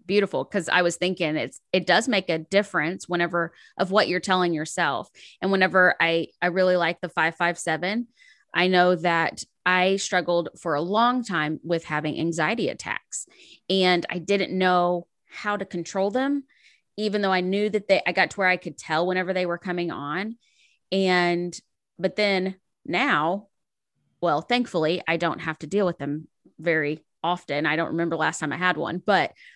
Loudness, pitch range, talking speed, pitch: -24 LUFS, 170-190 Hz, 185 wpm, 180 Hz